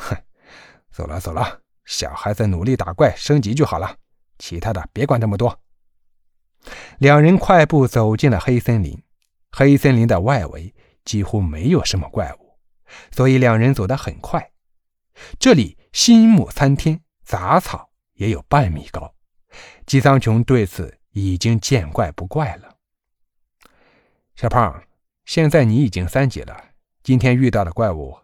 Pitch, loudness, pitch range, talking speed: 115 Hz, -17 LUFS, 95-140 Hz, 210 characters per minute